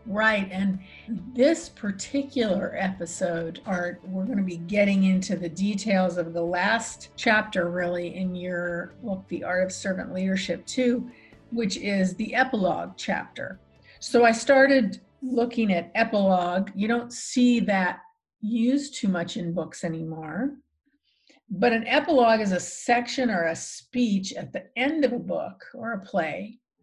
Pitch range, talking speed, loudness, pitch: 180-240 Hz, 150 wpm, -25 LUFS, 205 Hz